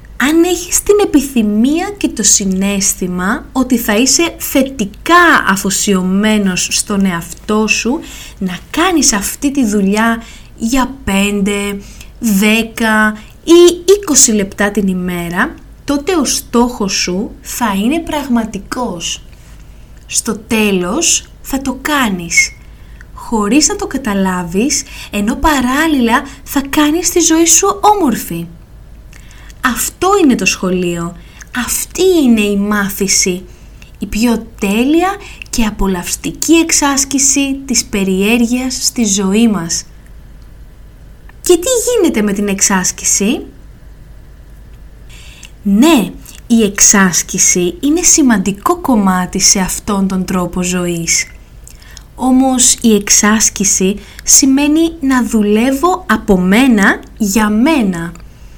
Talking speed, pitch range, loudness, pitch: 100 wpm, 200-285 Hz, -12 LUFS, 225 Hz